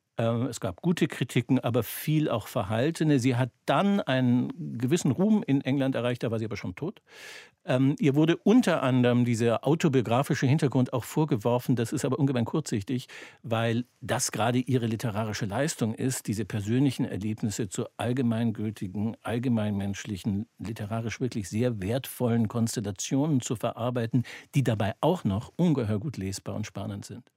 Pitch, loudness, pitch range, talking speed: 120 Hz, -28 LUFS, 115-135 Hz, 145 wpm